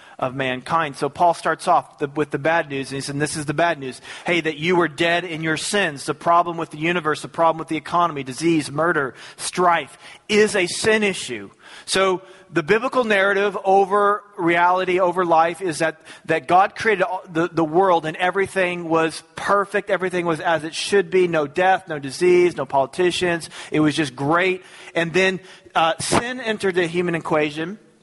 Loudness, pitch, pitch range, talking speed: -20 LUFS, 170 Hz, 160-185 Hz, 190 wpm